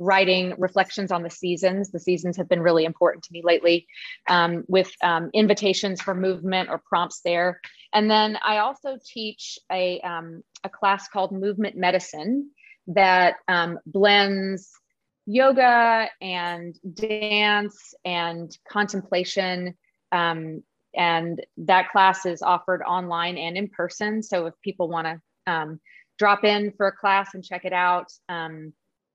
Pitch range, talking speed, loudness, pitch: 175-205 Hz, 140 wpm, -23 LUFS, 185 Hz